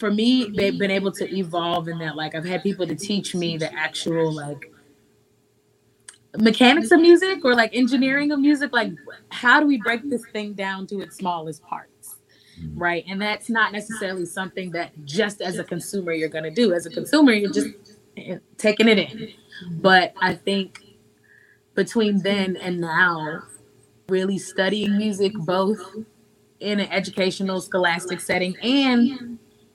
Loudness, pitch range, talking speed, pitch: -21 LUFS, 175-220 Hz, 155 wpm, 195 Hz